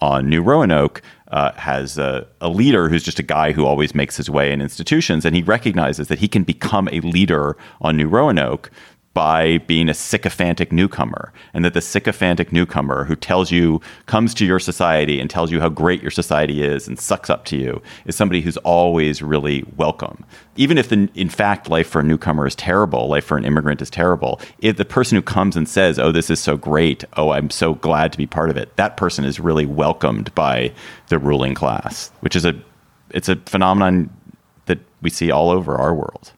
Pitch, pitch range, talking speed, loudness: 80 Hz, 75-90 Hz, 210 wpm, -18 LUFS